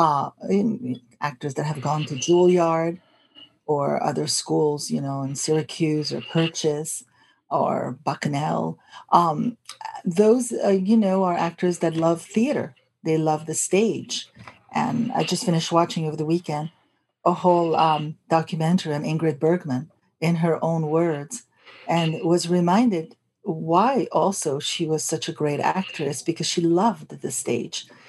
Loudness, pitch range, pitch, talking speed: -23 LUFS, 155-180 Hz, 165 Hz, 145 wpm